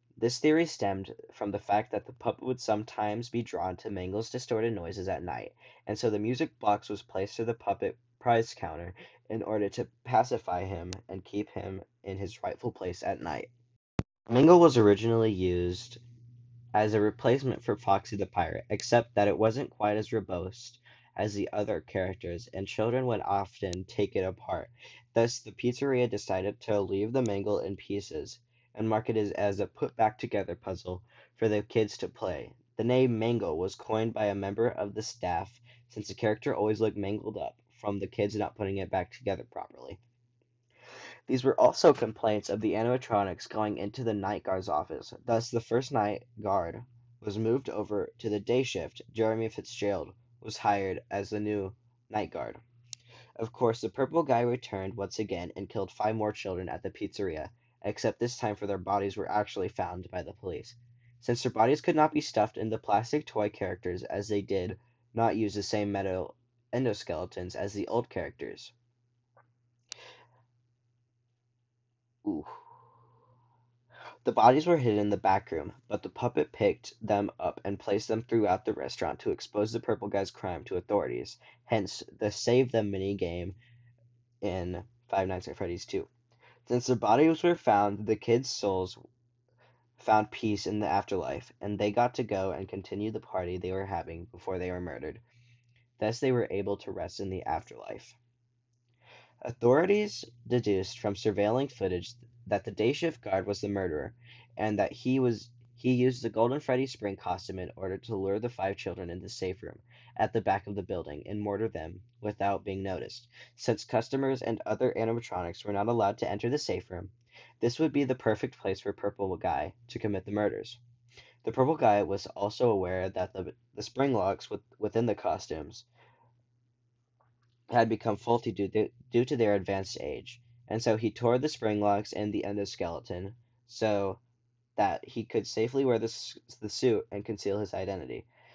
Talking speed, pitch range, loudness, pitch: 180 wpm, 100-120 Hz, -31 LUFS, 110 Hz